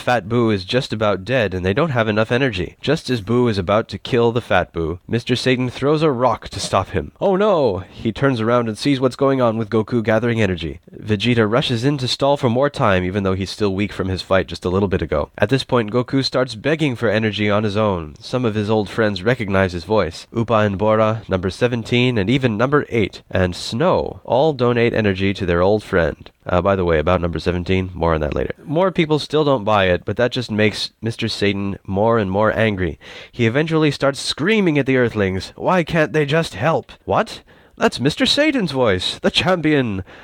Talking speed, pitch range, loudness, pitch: 220 wpm, 100-130 Hz, -18 LUFS, 115 Hz